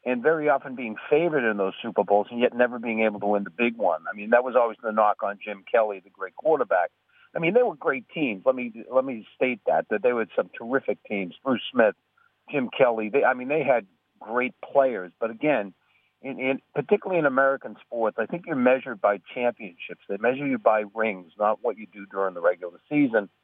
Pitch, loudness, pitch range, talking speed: 120 Hz, -25 LUFS, 105-135 Hz, 225 wpm